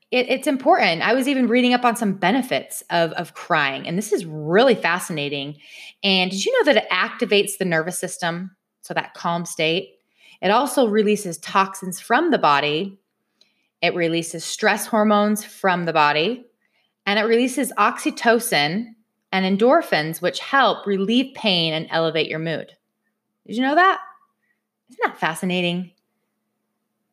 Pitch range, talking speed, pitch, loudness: 170-240 Hz, 150 wpm, 200 Hz, -20 LUFS